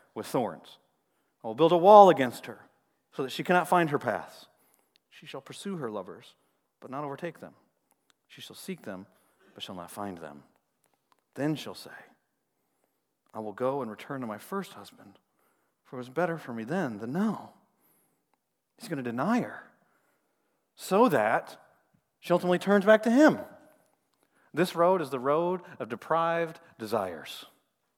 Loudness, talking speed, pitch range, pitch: -27 LUFS, 165 wpm, 125-180 Hz, 165 Hz